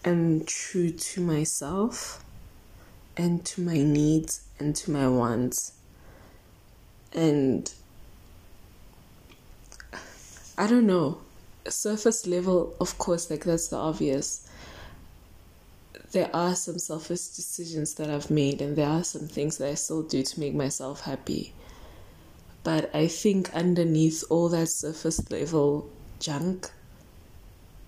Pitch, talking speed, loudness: 145 Hz, 115 wpm, -27 LUFS